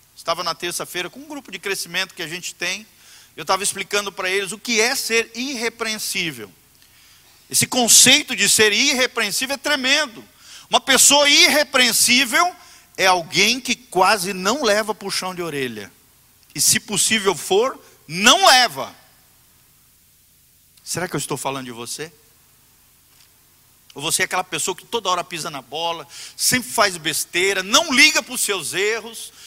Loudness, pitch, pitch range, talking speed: -17 LUFS, 200 Hz, 175-245 Hz, 155 wpm